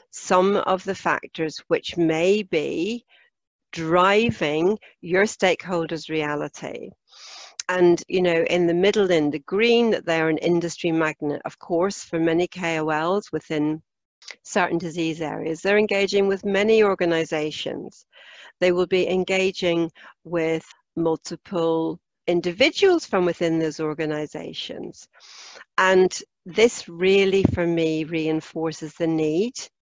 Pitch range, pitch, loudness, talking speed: 160-195 Hz, 170 Hz, -22 LUFS, 120 wpm